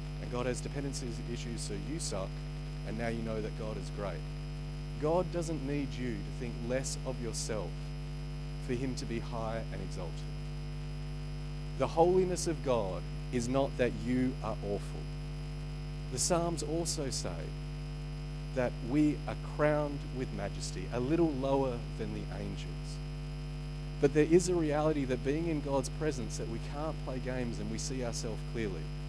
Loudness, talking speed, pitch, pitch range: -35 LUFS, 160 wpm, 150 Hz, 140-150 Hz